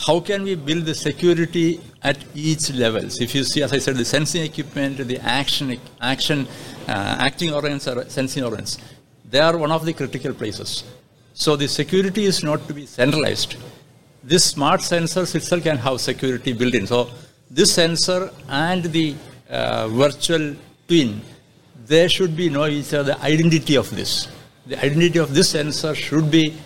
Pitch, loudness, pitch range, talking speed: 145 Hz, -20 LUFS, 130-165 Hz, 175 wpm